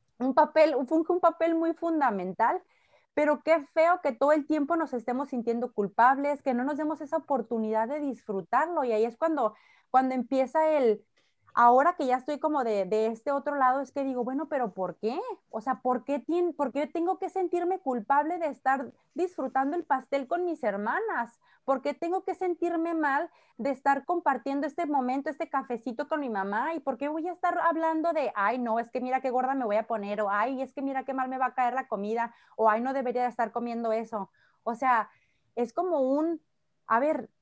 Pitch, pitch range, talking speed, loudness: 275 Hz, 245-320 Hz, 210 wpm, -28 LUFS